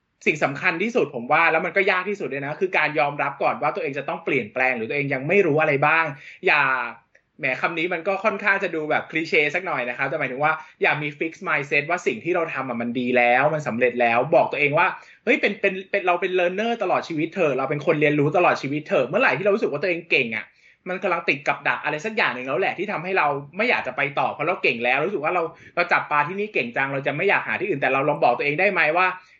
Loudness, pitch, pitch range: -22 LUFS, 160 Hz, 140-185 Hz